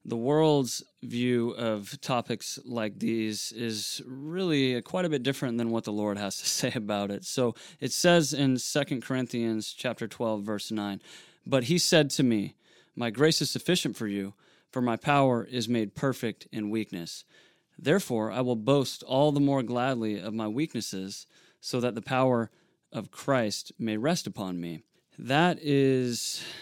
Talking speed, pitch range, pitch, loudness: 165 wpm, 110-140 Hz, 125 Hz, -28 LUFS